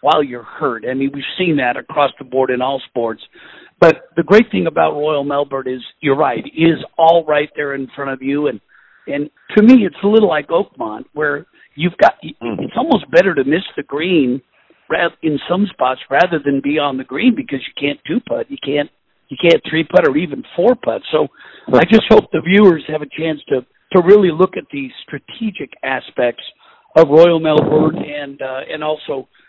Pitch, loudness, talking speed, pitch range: 150 Hz, -15 LUFS, 205 wpm, 140-175 Hz